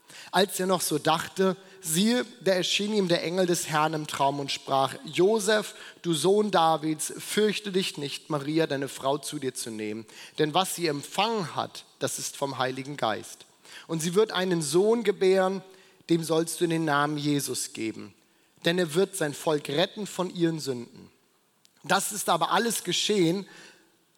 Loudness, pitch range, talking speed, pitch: -27 LUFS, 145-190 Hz, 170 wpm, 170 Hz